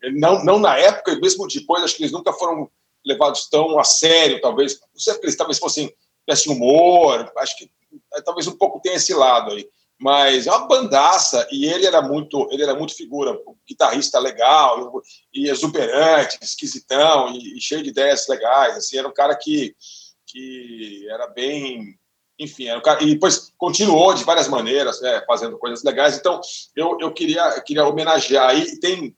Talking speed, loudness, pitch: 180 wpm, -17 LUFS, 165 Hz